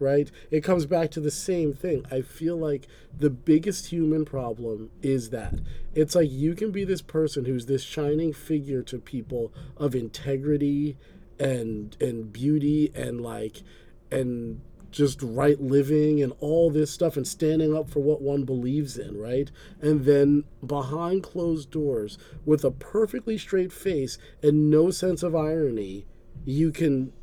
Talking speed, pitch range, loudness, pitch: 155 wpm, 130-155 Hz, -26 LUFS, 145 Hz